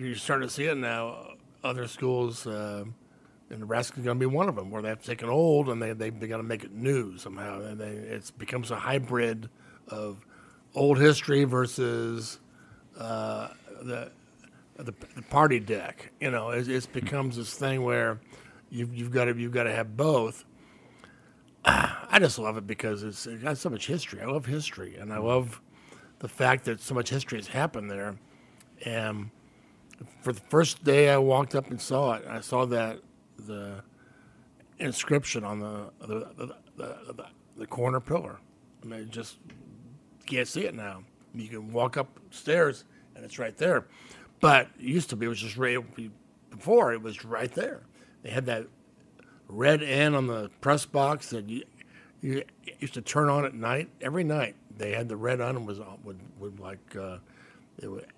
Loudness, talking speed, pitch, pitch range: -28 LUFS, 185 wpm, 120 Hz, 110-135 Hz